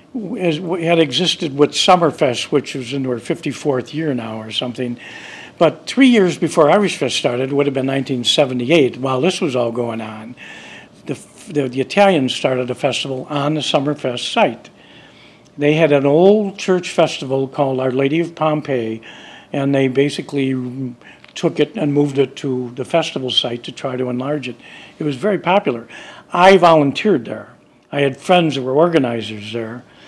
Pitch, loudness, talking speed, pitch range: 140 Hz, -17 LUFS, 170 wpm, 130-165 Hz